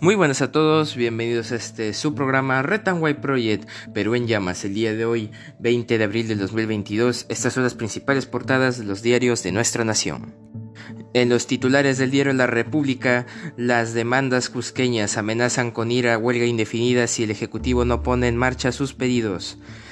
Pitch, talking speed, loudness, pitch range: 120 Hz, 185 wpm, -21 LUFS, 110-130 Hz